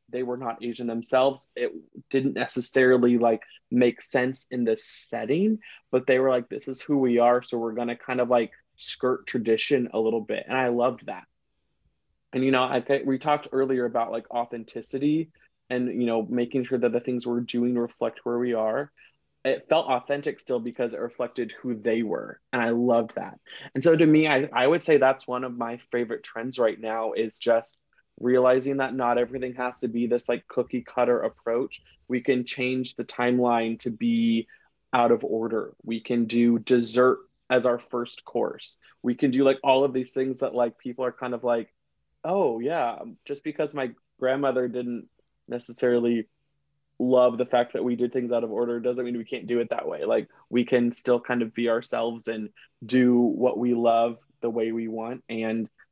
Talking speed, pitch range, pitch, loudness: 200 wpm, 120-130 Hz, 125 Hz, -26 LUFS